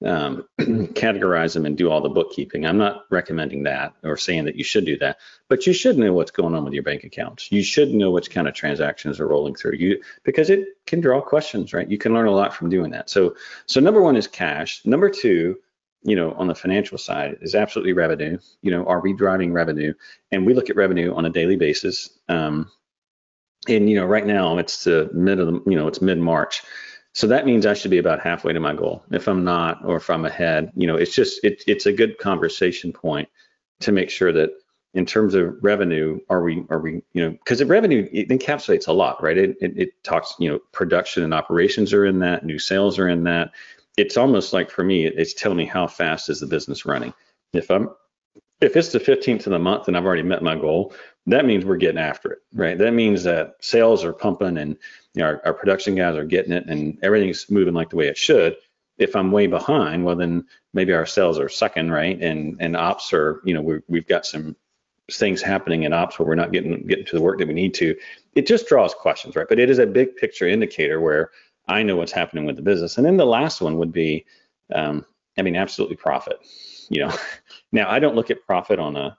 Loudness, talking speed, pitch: -20 LUFS, 235 wpm, 95 Hz